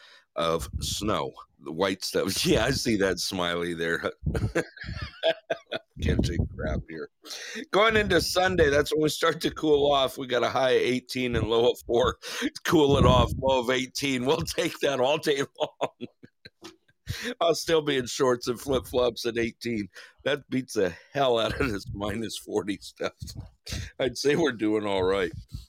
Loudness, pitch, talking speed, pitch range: -26 LUFS, 125 Hz, 170 wpm, 110-145 Hz